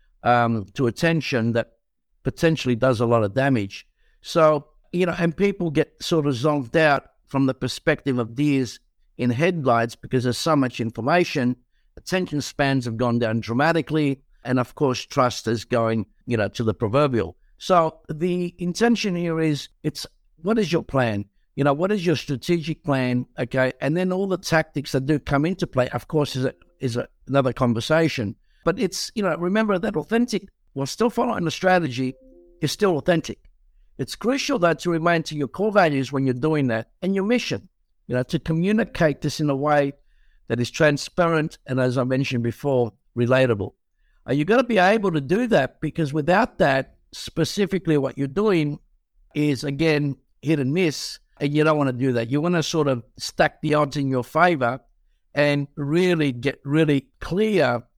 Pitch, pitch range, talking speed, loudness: 145 Hz, 125-170 Hz, 180 wpm, -22 LUFS